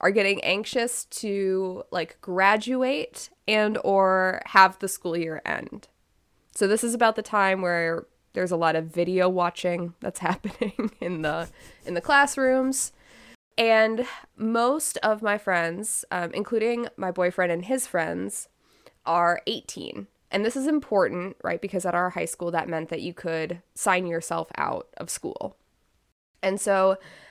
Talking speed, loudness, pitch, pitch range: 150 wpm, -25 LUFS, 190 Hz, 175-220 Hz